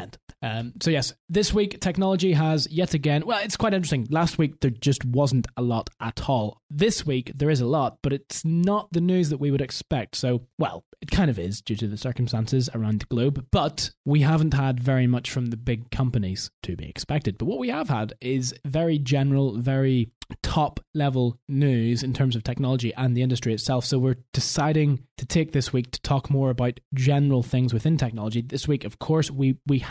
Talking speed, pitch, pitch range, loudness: 210 wpm, 135 Hz, 120-150 Hz, -25 LUFS